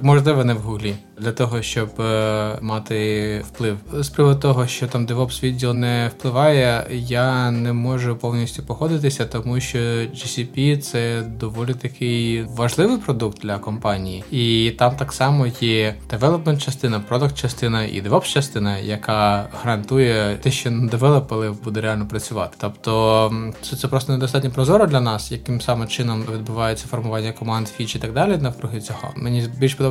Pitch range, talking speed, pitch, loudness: 110-130 Hz, 160 wpm, 120 Hz, -20 LUFS